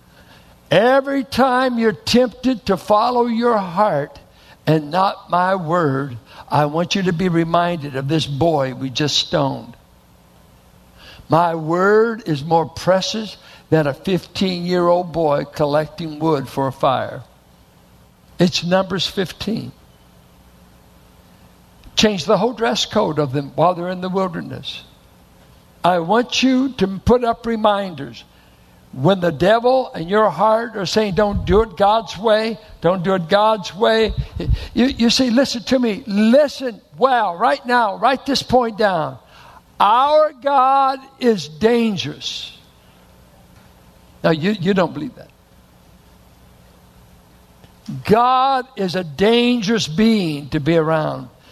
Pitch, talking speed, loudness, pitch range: 180 Hz, 130 wpm, -17 LUFS, 140-220 Hz